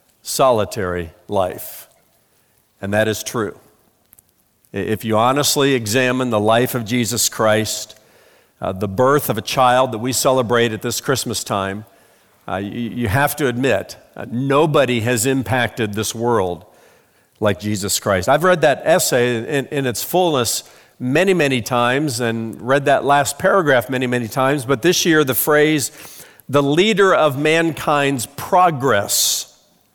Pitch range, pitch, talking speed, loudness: 110-140 Hz, 125 Hz, 145 wpm, -17 LUFS